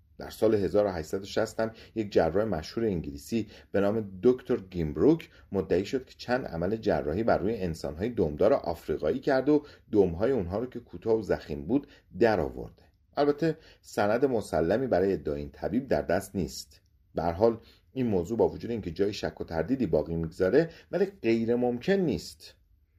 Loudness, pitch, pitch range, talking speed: -29 LUFS, 100 Hz, 85-120 Hz, 160 wpm